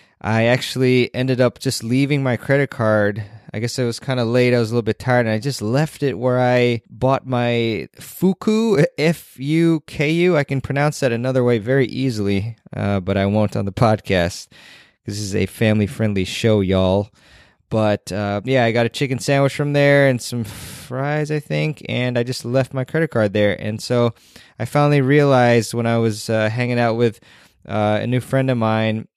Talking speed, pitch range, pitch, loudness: 205 wpm, 110-135 Hz, 120 Hz, -19 LUFS